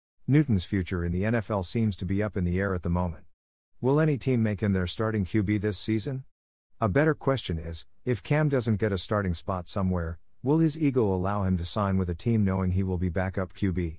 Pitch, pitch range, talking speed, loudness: 100 Hz, 90-115 Hz, 225 wpm, -27 LUFS